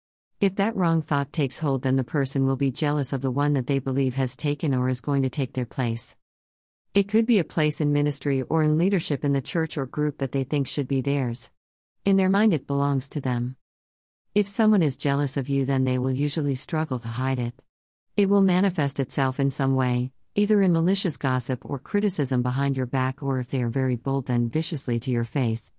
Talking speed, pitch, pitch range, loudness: 225 wpm, 135 Hz, 130-155 Hz, -25 LUFS